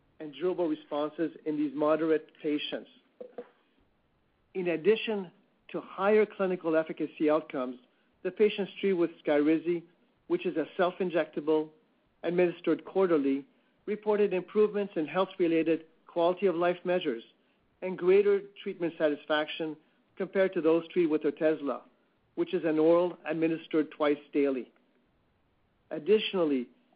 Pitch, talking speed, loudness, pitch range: 165 Hz, 115 wpm, -30 LUFS, 155-185 Hz